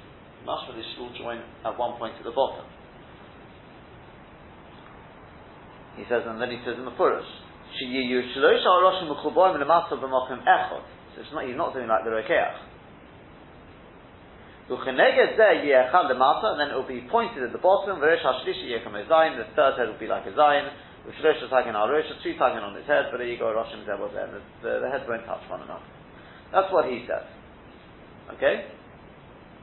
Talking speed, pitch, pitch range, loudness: 130 wpm, 130 Hz, 120-160 Hz, -24 LUFS